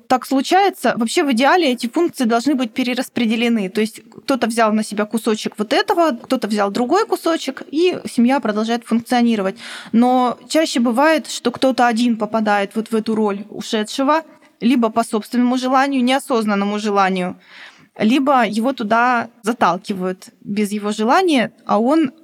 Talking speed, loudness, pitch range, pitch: 145 wpm, -17 LUFS, 220-270 Hz, 240 Hz